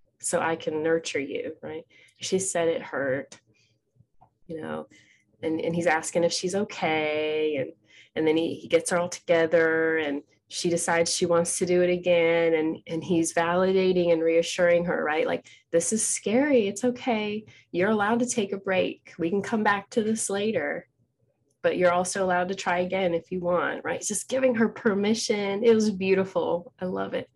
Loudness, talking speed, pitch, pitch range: -25 LUFS, 190 wpm, 175 Hz, 165-200 Hz